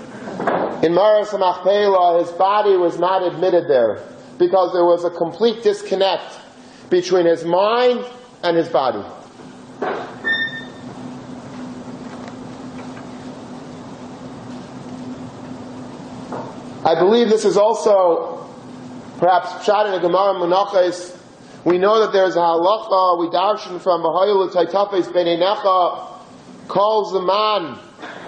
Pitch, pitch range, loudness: 185 Hz, 175-205 Hz, -17 LUFS